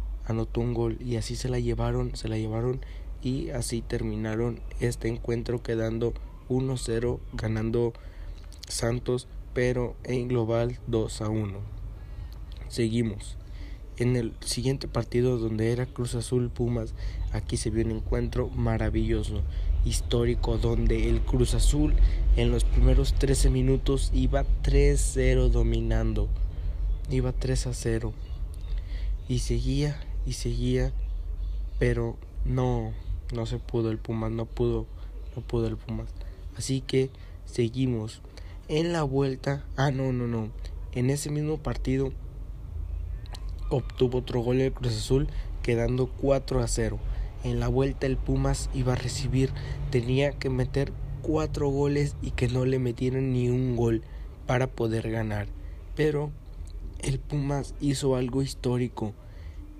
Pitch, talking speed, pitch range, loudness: 120 Hz, 130 wpm, 105-130 Hz, -29 LUFS